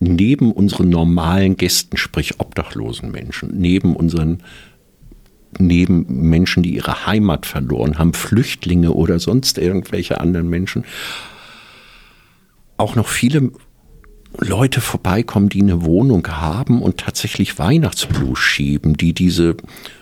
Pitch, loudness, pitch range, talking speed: 90 Hz, -16 LUFS, 85-100 Hz, 110 wpm